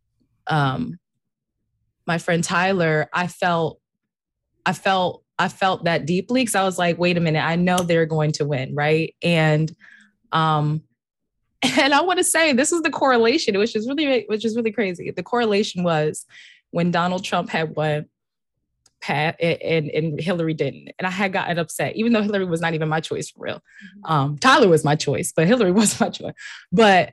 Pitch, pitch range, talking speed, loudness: 175 Hz, 155-210 Hz, 185 wpm, -20 LUFS